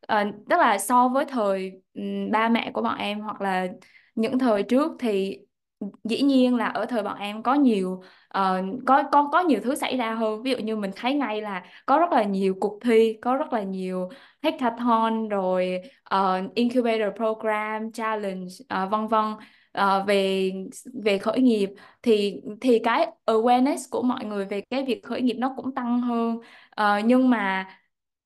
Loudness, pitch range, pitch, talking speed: -24 LUFS, 200-250 Hz, 220 Hz, 185 wpm